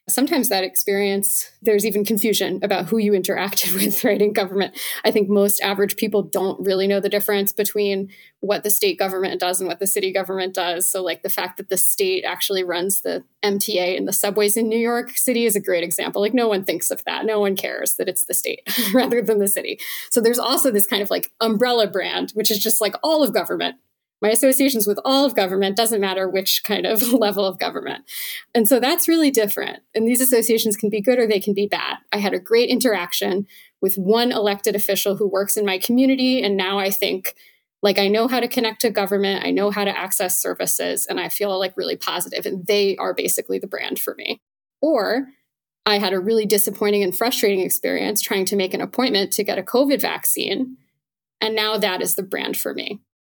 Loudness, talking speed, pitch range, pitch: -19 LUFS, 220 wpm, 195-230 Hz, 205 Hz